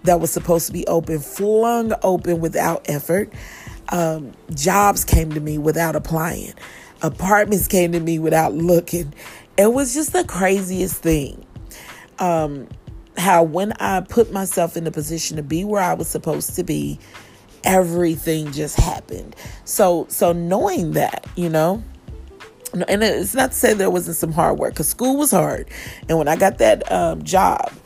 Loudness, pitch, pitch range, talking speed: -19 LUFS, 165 Hz, 155-185 Hz, 165 wpm